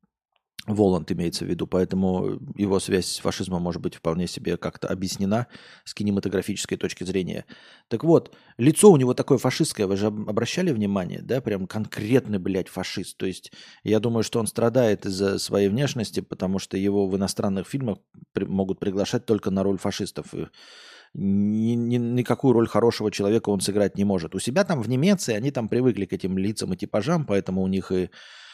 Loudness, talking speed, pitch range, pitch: -24 LUFS, 180 wpm, 95-115 Hz, 100 Hz